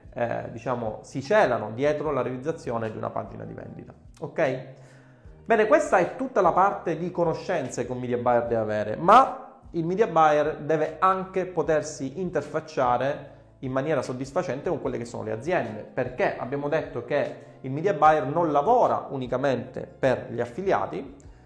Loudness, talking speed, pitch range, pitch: -25 LUFS, 160 wpm, 125-165 Hz, 145 Hz